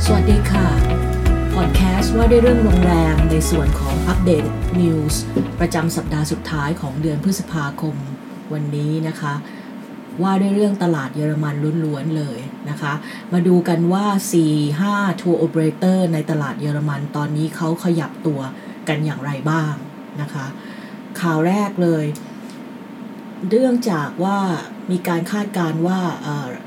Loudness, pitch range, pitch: -19 LUFS, 145-195 Hz, 160 Hz